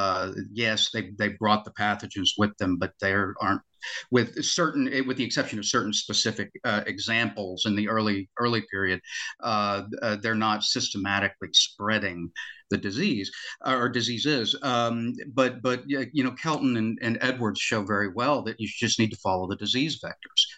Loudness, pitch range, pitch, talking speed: -26 LUFS, 105-125 Hz, 110 Hz, 170 wpm